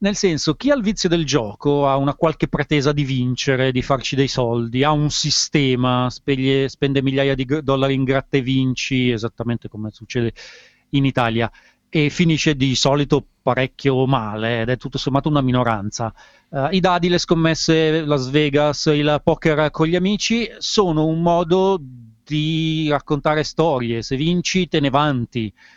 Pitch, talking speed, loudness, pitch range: 140 Hz, 165 wpm, -19 LUFS, 130-160 Hz